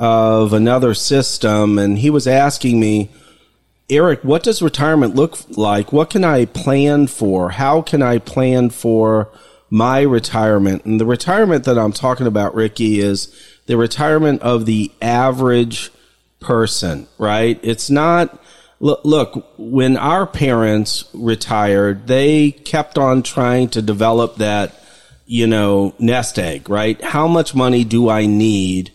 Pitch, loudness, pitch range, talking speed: 115 Hz, -15 LUFS, 105-135 Hz, 140 wpm